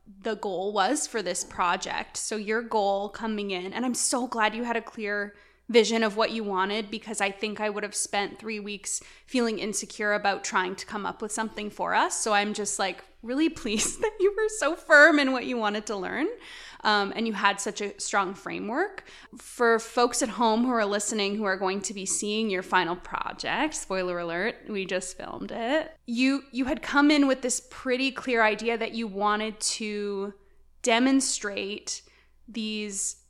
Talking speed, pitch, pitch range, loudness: 195 wpm, 220 Hz, 205-245 Hz, -27 LUFS